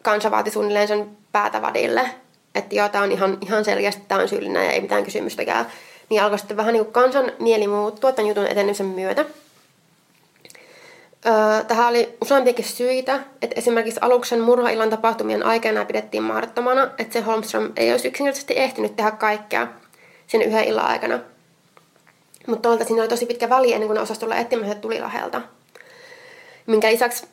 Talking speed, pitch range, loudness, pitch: 155 wpm, 210-255 Hz, -20 LUFS, 225 Hz